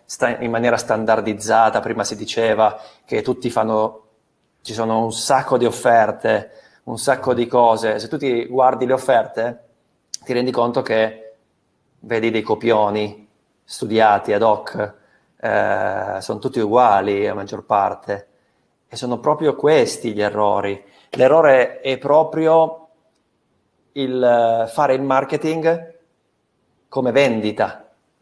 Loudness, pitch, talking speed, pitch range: -18 LUFS, 115 Hz, 120 wpm, 110-130 Hz